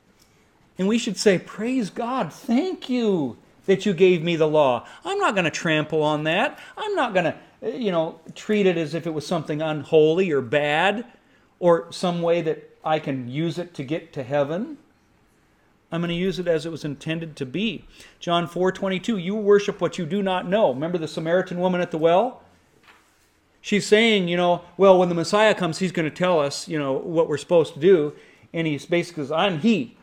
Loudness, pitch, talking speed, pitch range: -22 LUFS, 175 Hz, 205 wpm, 160-200 Hz